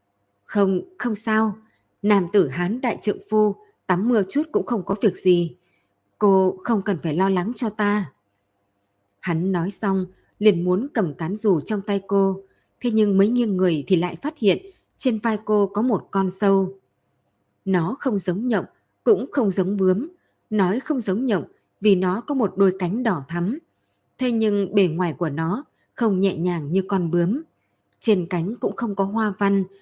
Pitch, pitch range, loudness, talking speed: 195 Hz, 180-220 Hz, -22 LUFS, 185 wpm